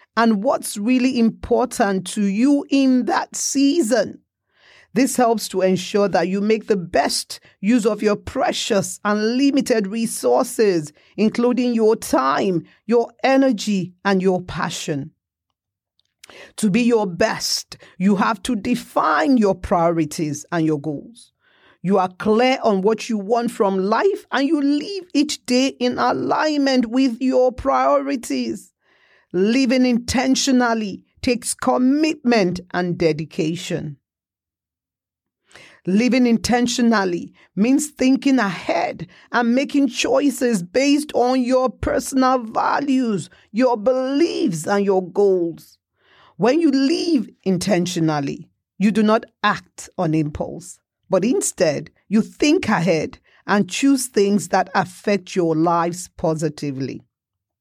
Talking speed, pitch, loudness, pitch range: 115 wpm, 220 Hz, -19 LUFS, 185-255 Hz